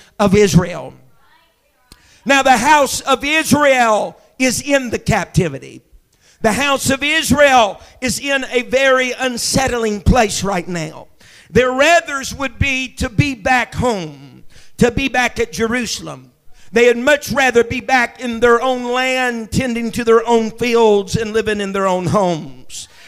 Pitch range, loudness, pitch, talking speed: 220-265 Hz, -15 LUFS, 245 Hz, 150 wpm